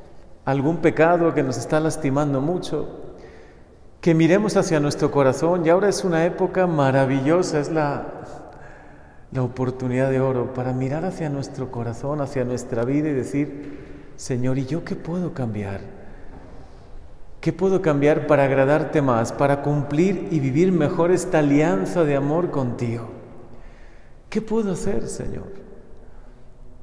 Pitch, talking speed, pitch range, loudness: 150 Hz, 135 wpm, 135-170 Hz, -21 LUFS